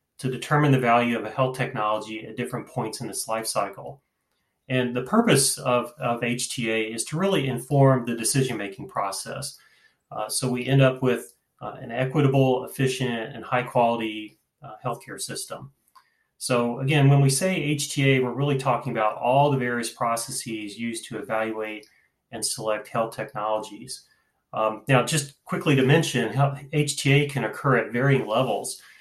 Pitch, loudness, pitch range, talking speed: 125 Hz, -24 LUFS, 115-140 Hz, 160 wpm